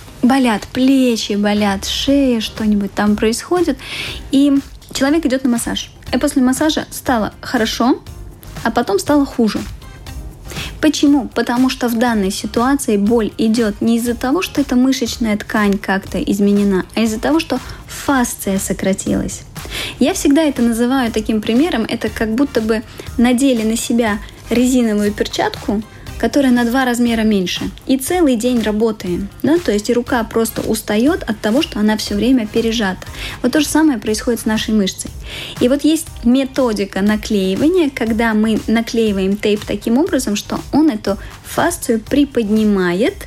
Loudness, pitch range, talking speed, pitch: -16 LUFS, 215-265 Hz, 145 wpm, 235 Hz